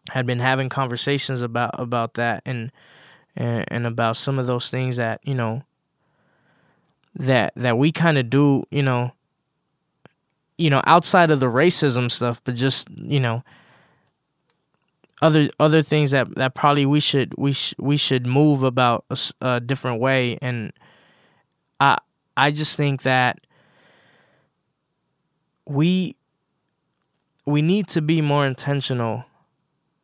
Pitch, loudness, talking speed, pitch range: 135 Hz, -20 LUFS, 135 wpm, 125-155 Hz